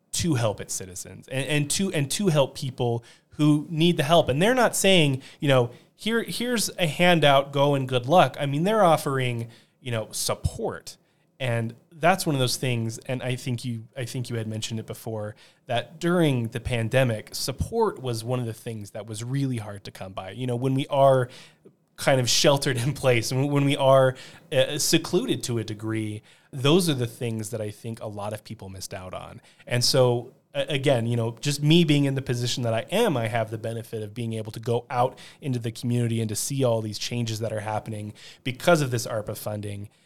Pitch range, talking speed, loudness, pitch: 115-150 Hz, 215 wpm, -24 LUFS, 130 Hz